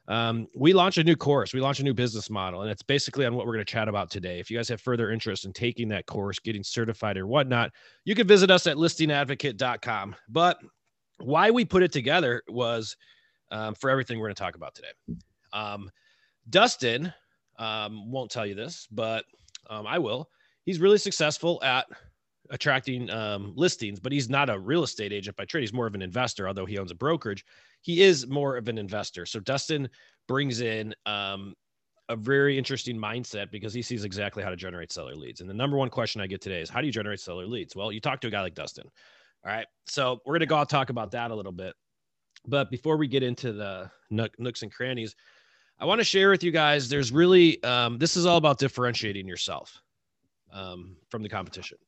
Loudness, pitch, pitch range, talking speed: -26 LUFS, 120 Hz, 105-140 Hz, 215 wpm